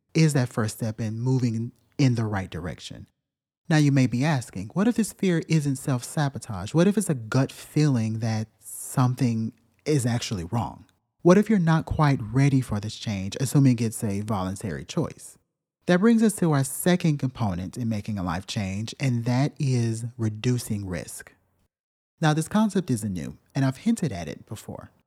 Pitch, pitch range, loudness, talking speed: 125 Hz, 110-150 Hz, -25 LUFS, 175 wpm